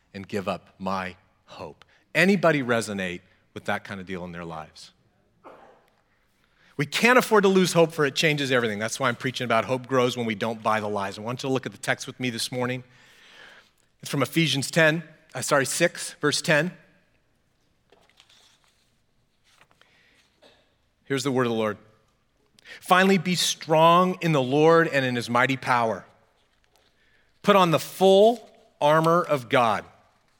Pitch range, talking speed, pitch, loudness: 115-165 Hz, 165 wpm, 135 Hz, -23 LUFS